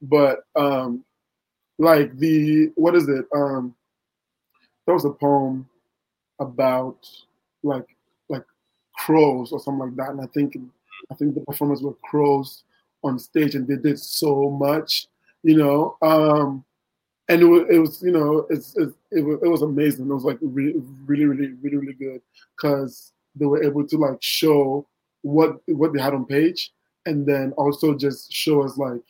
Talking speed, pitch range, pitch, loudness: 170 wpm, 135-155 Hz, 145 Hz, -21 LUFS